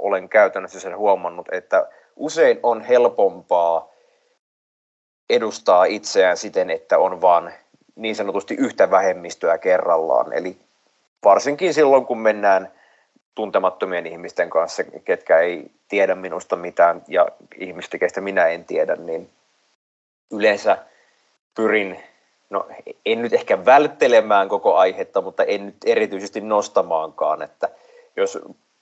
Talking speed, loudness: 115 wpm, -19 LUFS